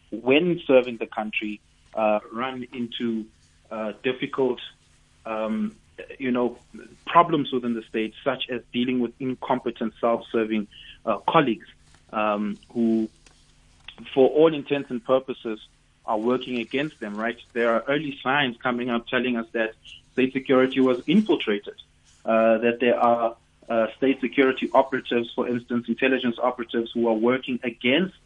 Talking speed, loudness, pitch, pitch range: 140 wpm, -24 LUFS, 120 Hz, 110-130 Hz